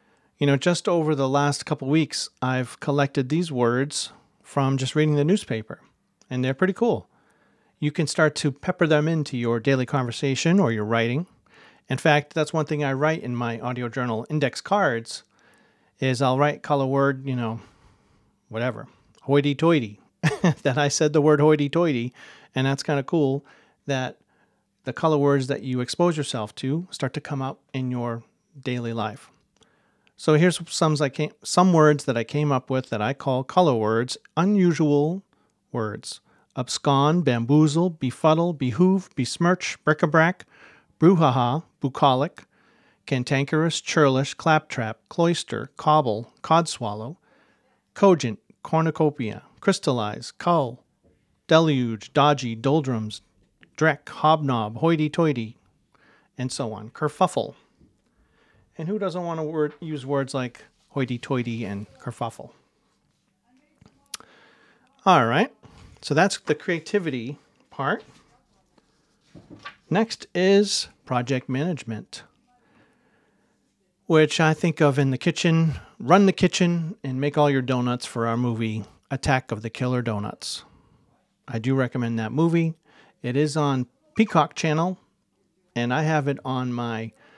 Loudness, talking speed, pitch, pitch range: -23 LUFS, 135 wpm, 145 Hz, 125-160 Hz